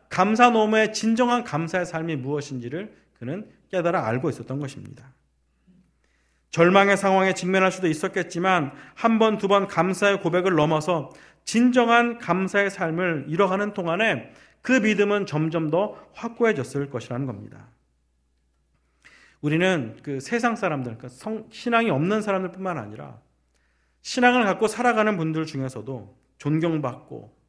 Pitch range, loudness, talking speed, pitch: 130-205 Hz, -23 LUFS, 300 characters per minute, 170 Hz